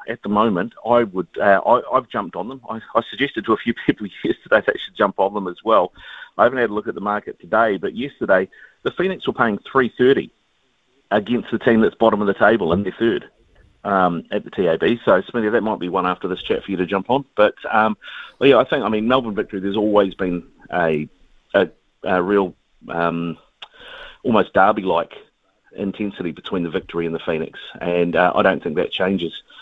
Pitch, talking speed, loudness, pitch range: 95 Hz, 215 wpm, -19 LUFS, 85-105 Hz